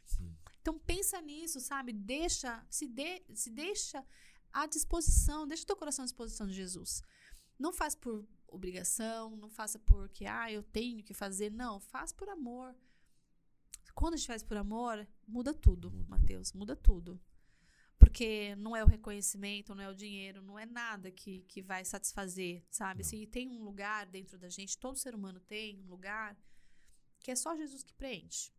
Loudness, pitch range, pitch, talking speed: -37 LUFS, 195-260 Hz, 220 Hz, 170 wpm